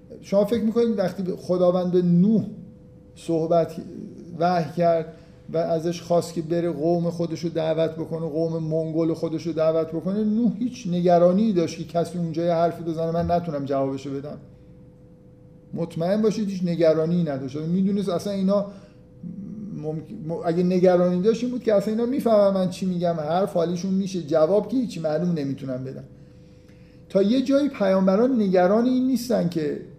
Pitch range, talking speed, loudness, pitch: 165-200 Hz, 155 wpm, -23 LUFS, 175 Hz